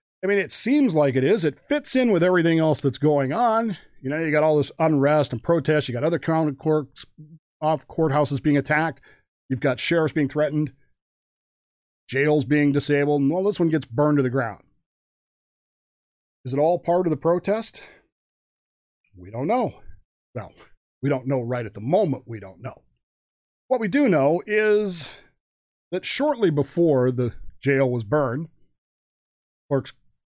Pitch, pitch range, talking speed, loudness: 150 Hz, 135-170 Hz, 170 wpm, -22 LUFS